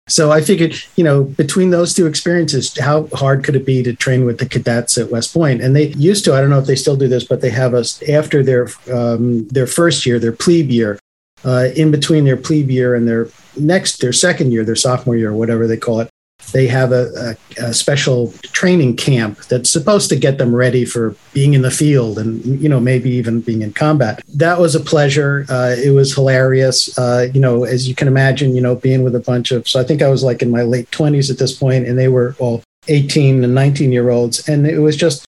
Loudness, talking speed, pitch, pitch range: -14 LUFS, 235 wpm, 130 Hz, 120-150 Hz